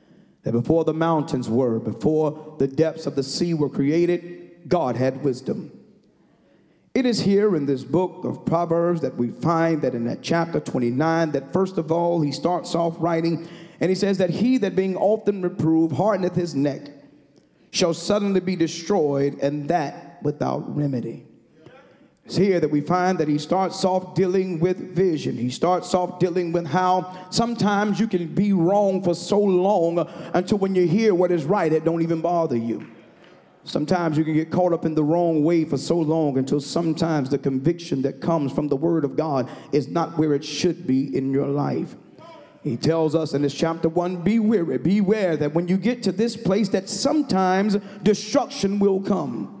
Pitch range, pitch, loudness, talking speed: 150-185 Hz, 170 Hz, -22 LUFS, 185 wpm